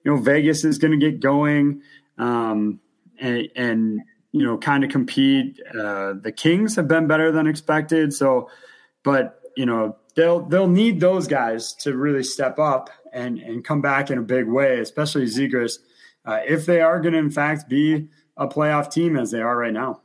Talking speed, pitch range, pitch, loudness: 190 wpm, 125-160 Hz, 145 Hz, -20 LUFS